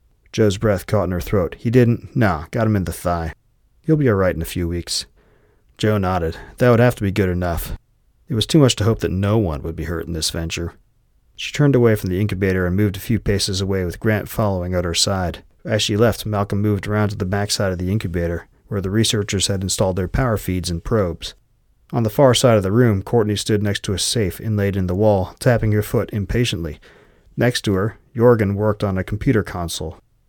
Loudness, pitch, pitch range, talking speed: -19 LUFS, 100 Hz, 90-110 Hz, 230 wpm